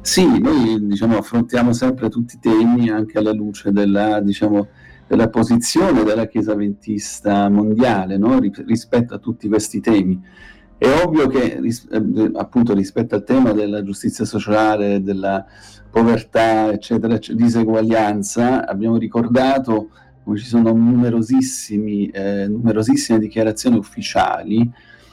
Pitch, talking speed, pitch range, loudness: 110 Hz, 125 wpm, 105-115 Hz, -17 LUFS